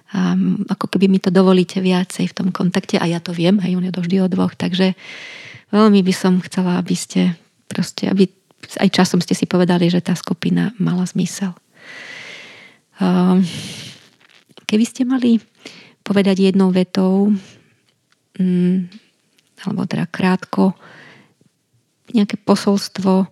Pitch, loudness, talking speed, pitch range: 190 Hz, -17 LUFS, 130 wpm, 180-200 Hz